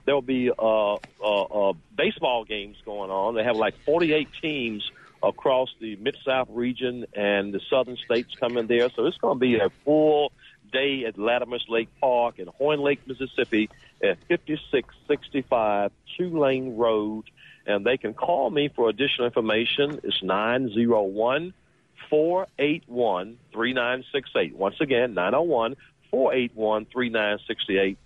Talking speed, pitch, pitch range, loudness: 175 wpm, 120 Hz, 110-140 Hz, -25 LUFS